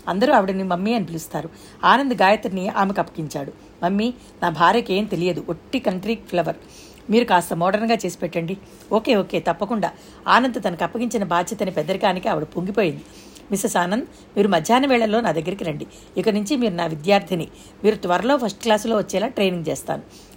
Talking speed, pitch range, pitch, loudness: 155 wpm, 175-225 Hz, 195 Hz, -21 LUFS